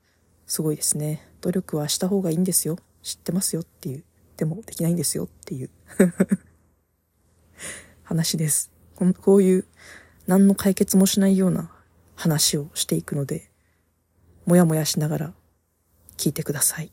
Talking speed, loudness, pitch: 300 characters per minute, -22 LUFS, 155 Hz